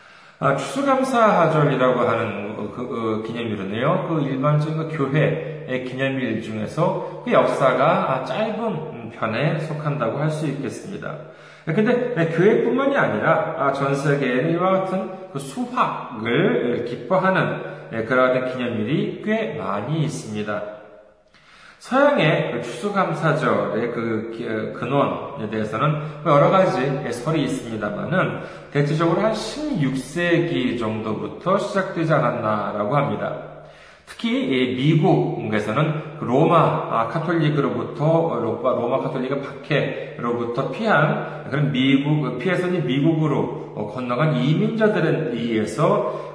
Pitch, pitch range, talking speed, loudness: 150 Hz, 120-175 Hz, 265 characters per minute, -21 LUFS